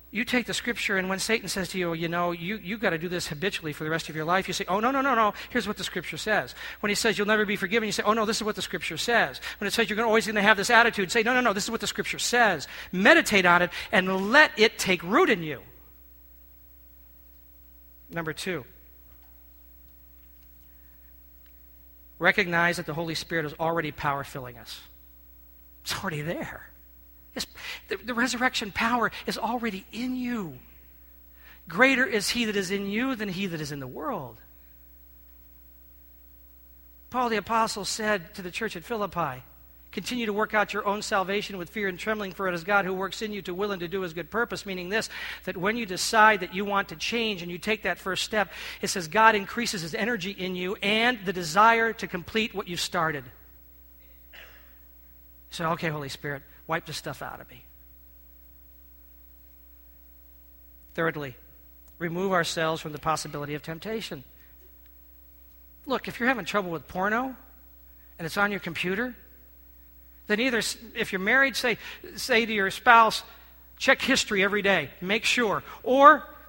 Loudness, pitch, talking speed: -26 LUFS, 180 Hz, 185 wpm